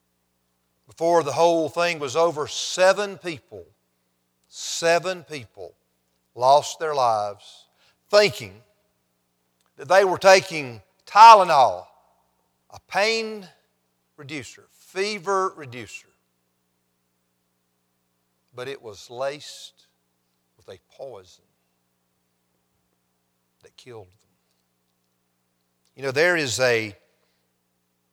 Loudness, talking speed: -19 LUFS, 85 wpm